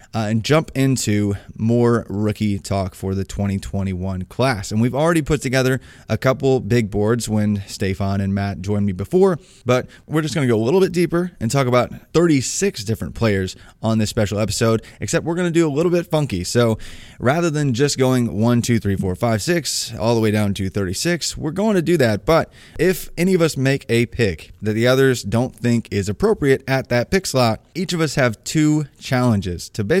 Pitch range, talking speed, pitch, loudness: 105-145 Hz, 210 wpm, 120 Hz, -19 LUFS